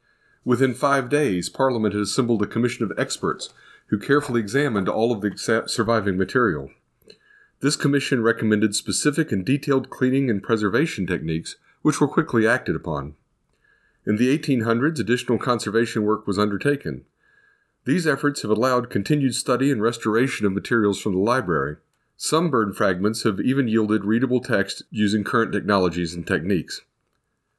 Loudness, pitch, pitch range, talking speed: -22 LUFS, 115 Hz, 105-135 Hz, 150 wpm